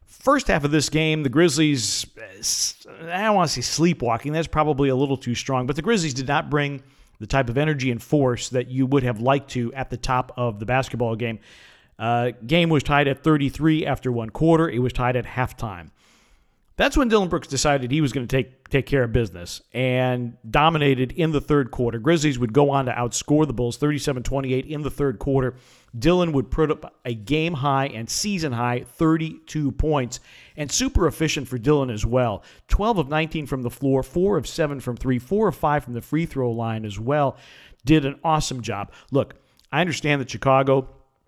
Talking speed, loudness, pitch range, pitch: 205 wpm, -22 LUFS, 125-155 Hz, 135 Hz